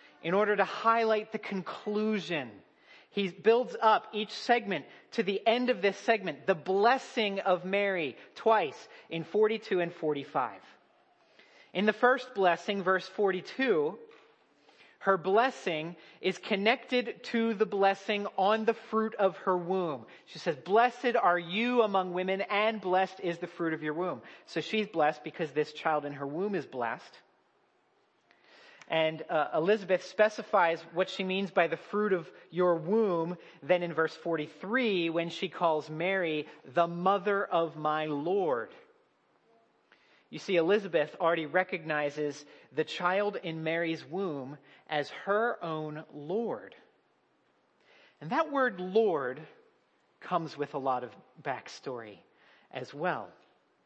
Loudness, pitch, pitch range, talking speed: -30 LUFS, 190 Hz, 165-220 Hz, 135 wpm